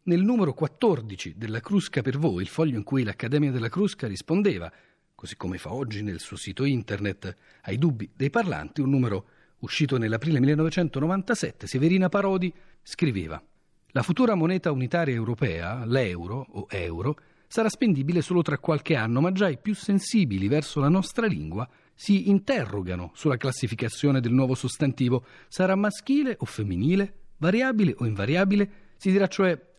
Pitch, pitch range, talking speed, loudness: 145 Hz, 120-185 Hz, 150 wpm, -26 LUFS